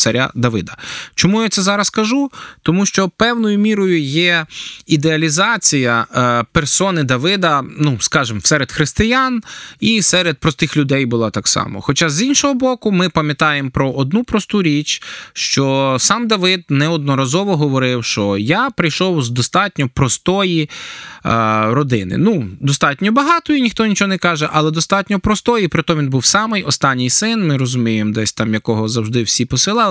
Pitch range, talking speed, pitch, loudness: 130-200 Hz, 150 wpm, 160 Hz, -15 LUFS